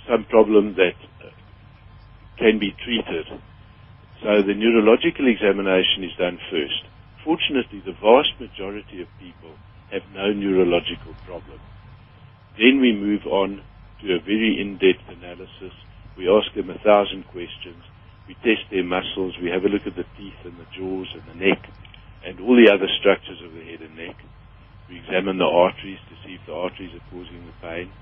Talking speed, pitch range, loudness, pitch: 170 wpm, 95-105 Hz, -20 LUFS, 100 Hz